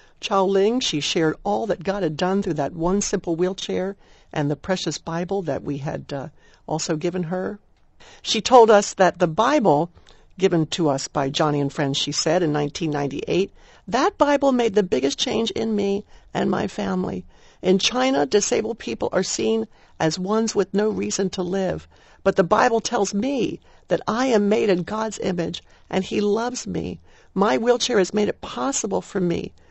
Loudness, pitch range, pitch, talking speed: -22 LUFS, 170-215 Hz, 195 Hz, 180 wpm